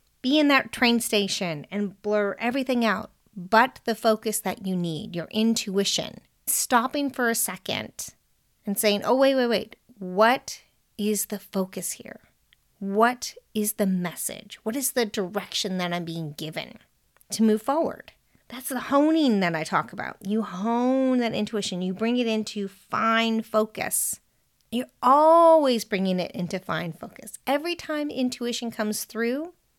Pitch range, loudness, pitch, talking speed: 200-245 Hz, -25 LUFS, 220 Hz, 155 wpm